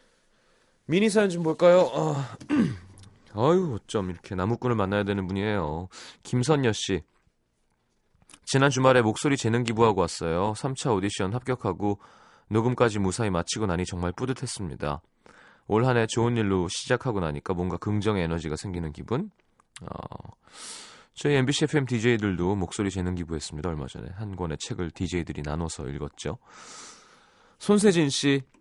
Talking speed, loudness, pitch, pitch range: 315 characters per minute, -26 LUFS, 110 Hz, 90-130 Hz